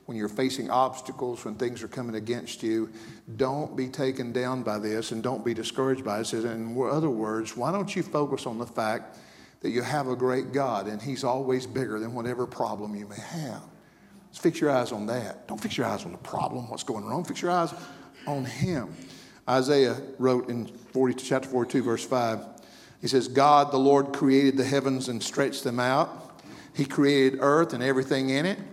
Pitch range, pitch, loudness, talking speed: 120-135 Hz, 130 Hz, -27 LUFS, 205 wpm